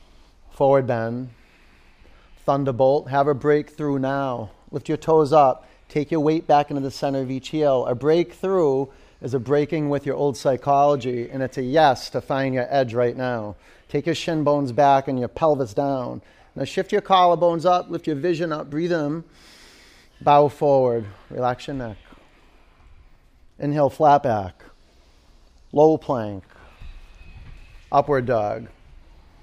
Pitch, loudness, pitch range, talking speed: 135 Hz, -21 LUFS, 115-150 Hz, 145 wpm